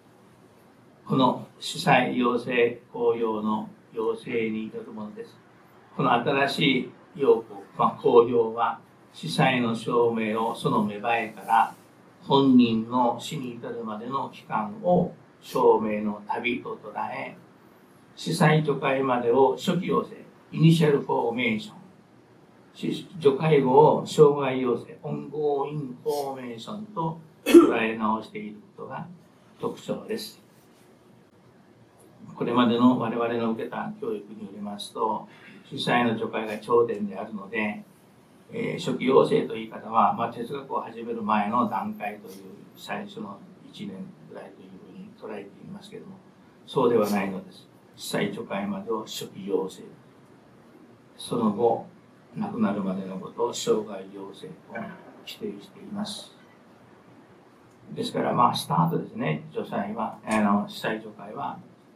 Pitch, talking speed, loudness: 125 Hz, 255 characters per minute, -25 LUFS